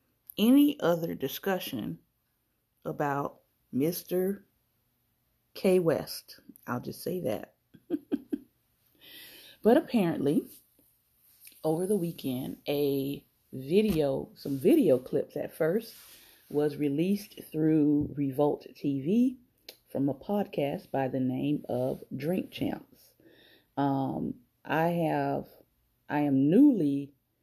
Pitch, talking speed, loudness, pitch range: 150 Hz, 95 wpm, -29 LUFS, 140-200 Hz